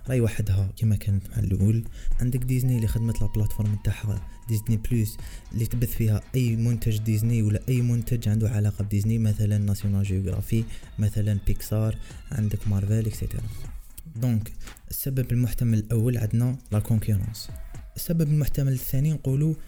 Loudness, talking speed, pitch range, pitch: -26 LUFS, 135 wpm, 105-120 Hz, 110 Hz